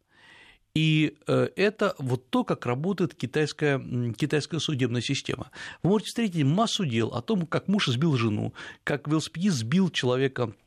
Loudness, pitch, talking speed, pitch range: -27 LUFS, 150 Hz, 140 wpm, 130-180 Hz